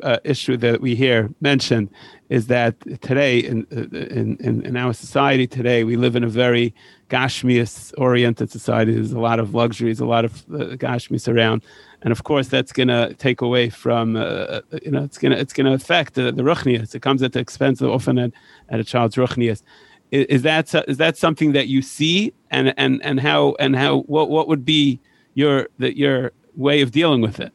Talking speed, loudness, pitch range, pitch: 205 wpm, -19 LUFS, 120-140 Hz, 125 Hz